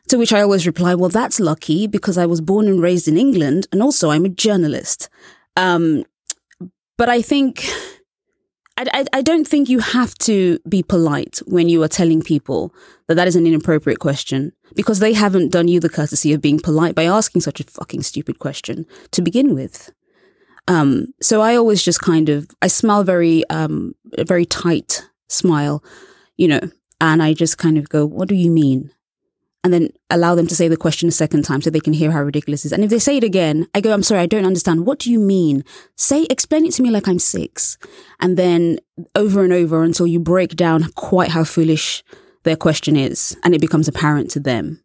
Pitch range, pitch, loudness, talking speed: 160-205 Hz, 175 Hz, -16 LUFS, 210 wpm